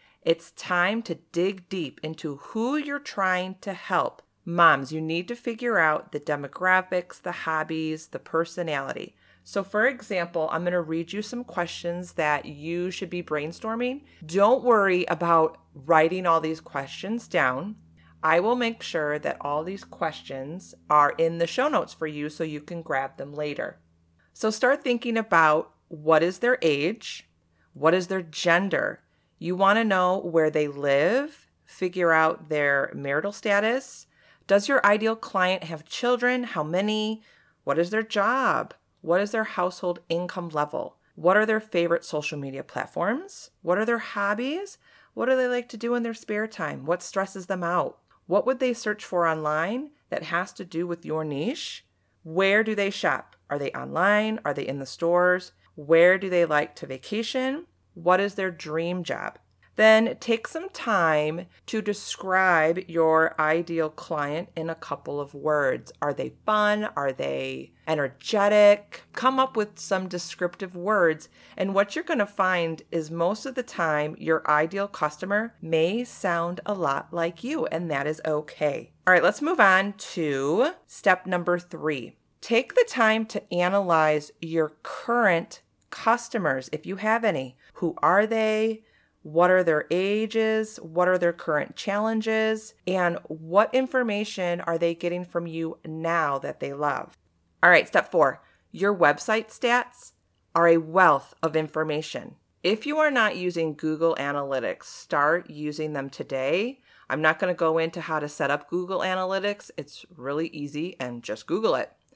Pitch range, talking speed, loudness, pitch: 160-210 Hz, 165 wpm, -25 LUFS, 175 Hz